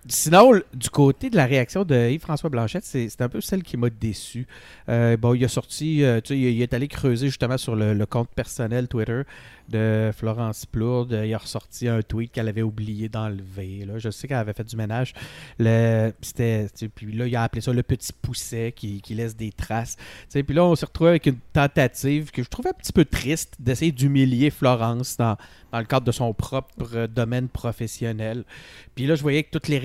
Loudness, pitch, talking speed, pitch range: -23 LUFS, 120 Hz, 225 wpm, 115-140 Hz